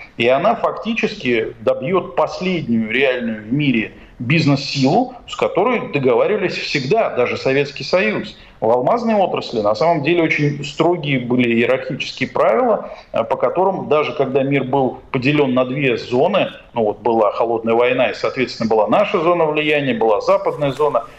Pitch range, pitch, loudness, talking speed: 125-165 Hz, 140 Hz, -17 LUFS, 145 wpm